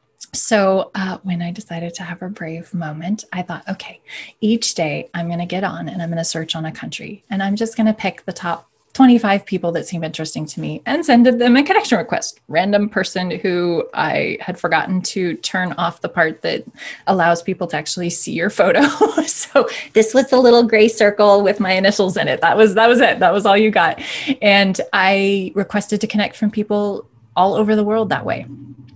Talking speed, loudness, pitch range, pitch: 215 wpm, -16 LUFS, 175-215 Hz, 195 Hz